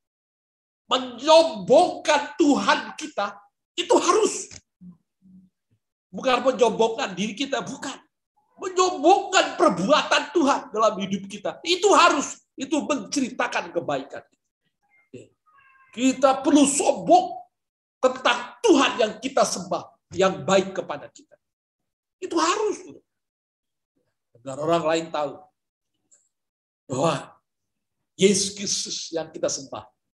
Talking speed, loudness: 90 wpm, -22 LUFS